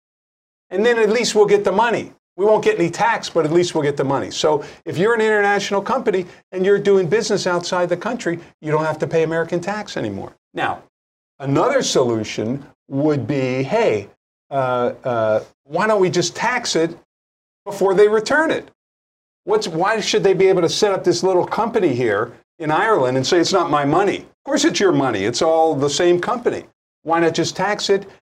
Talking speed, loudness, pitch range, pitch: 200 wpm, -18 LUFS, 160-205 Hz, 180 Hz